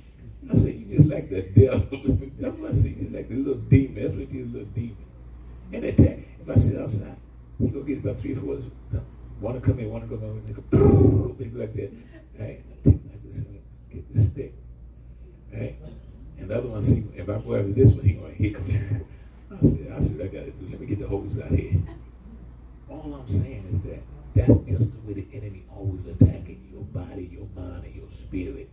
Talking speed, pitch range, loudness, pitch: 235 wpm, 95-115 Hz, -25 LUFS, 100 Hz